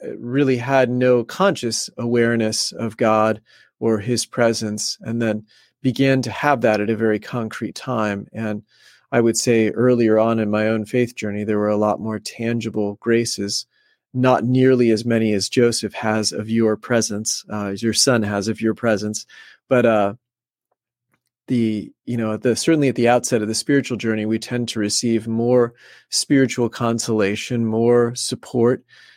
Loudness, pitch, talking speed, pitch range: -19 LUFS, 115 Hz, 165 wpm, 110-120 Hz